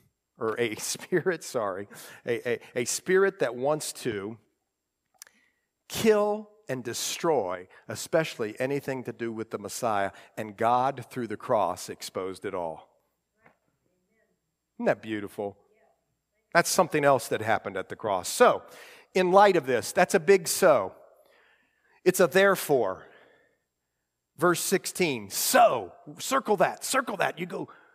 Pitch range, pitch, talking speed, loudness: 115-190 Hz, 150 Hz, 130 wpm, -26 LUFS